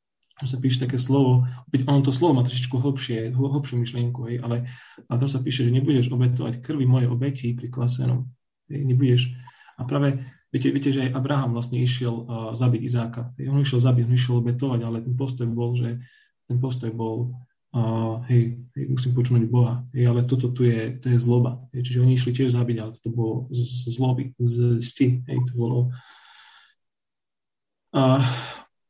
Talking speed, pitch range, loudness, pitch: 175 wpm, 120-130 Hz, -23 LUFS, 125 Hz